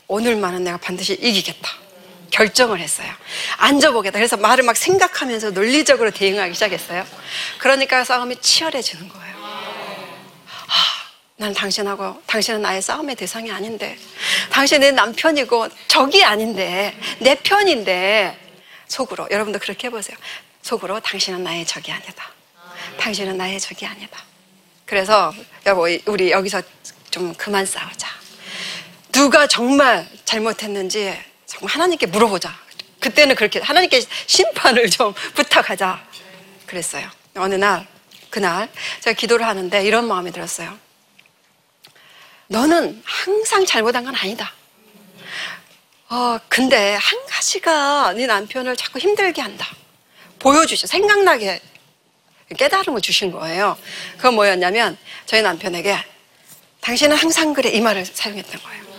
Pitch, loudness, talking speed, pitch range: 215 Hz, -17 LUFS, 295 characters per minute, 190-270 Hz